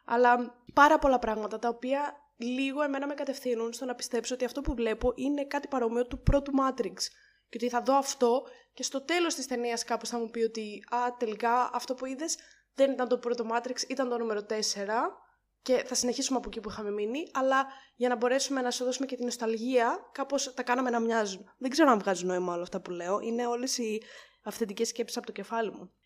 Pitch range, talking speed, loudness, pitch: 230-270 Hz, 215 wpm, -30 LUFS, 245 Hz